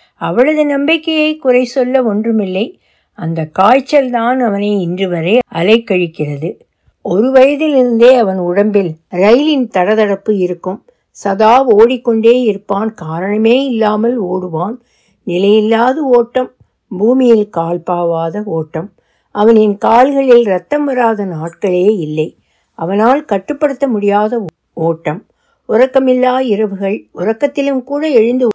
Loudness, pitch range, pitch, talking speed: -12 LUFS, 185-255 Hz, 220 Hz, 95 wpm